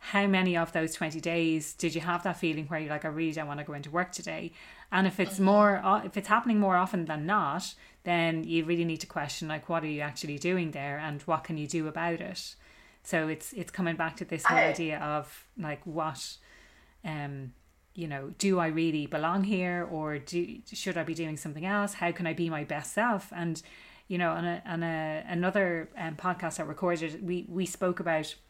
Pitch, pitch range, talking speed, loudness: 165 Hz, 155-180 Hz, 220 wpm, -31 LUFS